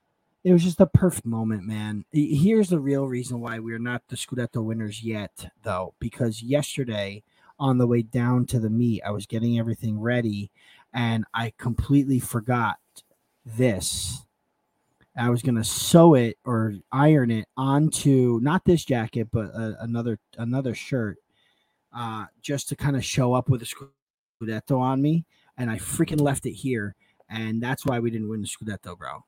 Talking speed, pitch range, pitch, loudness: 170 wpm, 110-135 Hz, 120 Hz, -24 LUFS